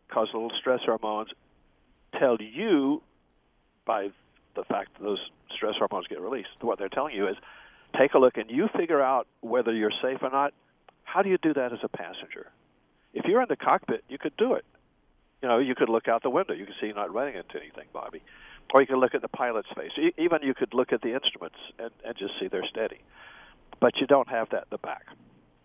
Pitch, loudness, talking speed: 110 Hz, -27 LUFS, 220 wpm